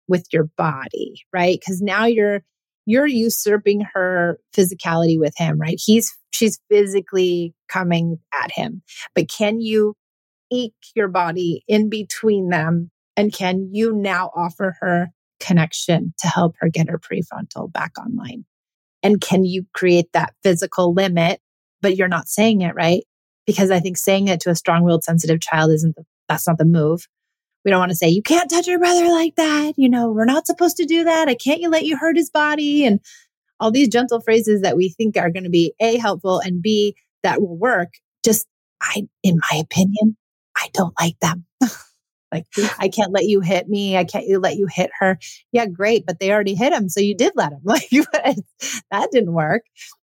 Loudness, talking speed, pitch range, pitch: -18 LUFS, 190 wpm, 175-225 Hz, 195 Hz